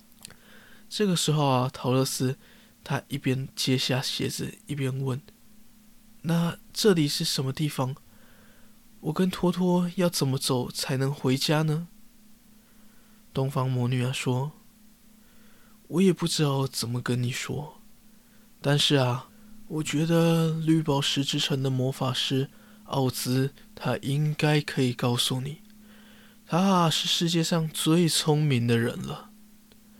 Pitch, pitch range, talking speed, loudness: 155 Hz, 135-215 Hz, 180 characters per minute, -26 LUFS